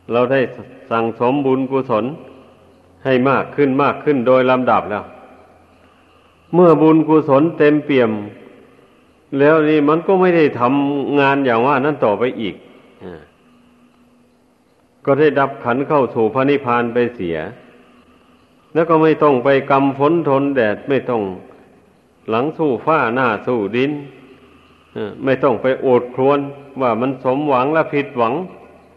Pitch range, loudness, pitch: 130-145 Hz, -16 LUFS, 135 Hz